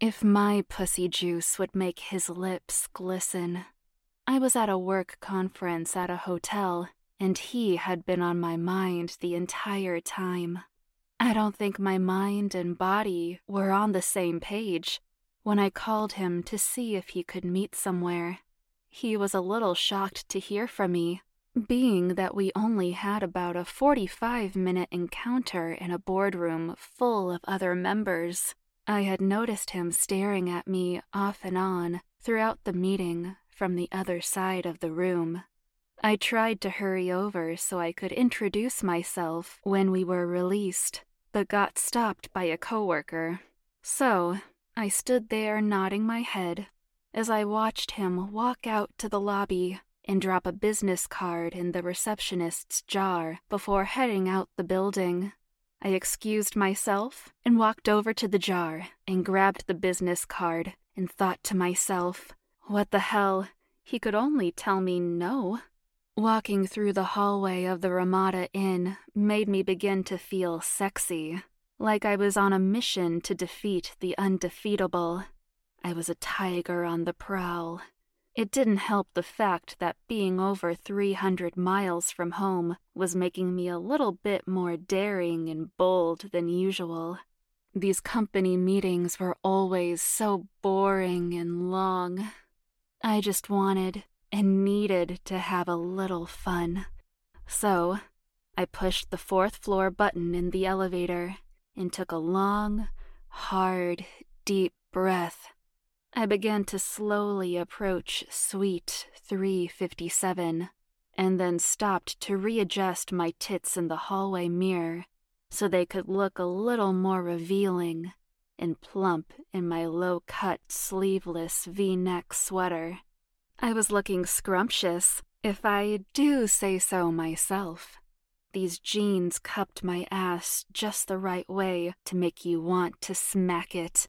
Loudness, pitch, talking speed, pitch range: -29 LUFS, 190 Hz, 145 wpm, 175-200 Hz